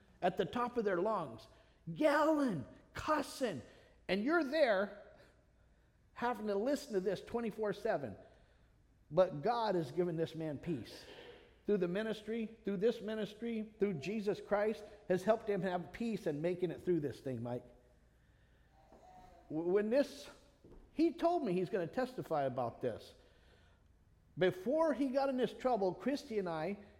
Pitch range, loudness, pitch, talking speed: 175-245 Hz, -37 LUFS, 205 Hz, 145 wpm